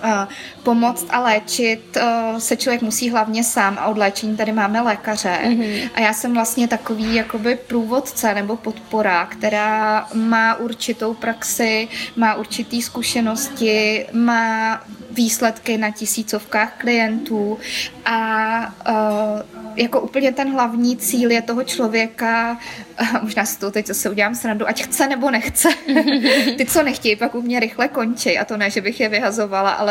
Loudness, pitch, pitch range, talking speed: -18 LUFS, 225 Hz, 215-240 Hz, 145 wpm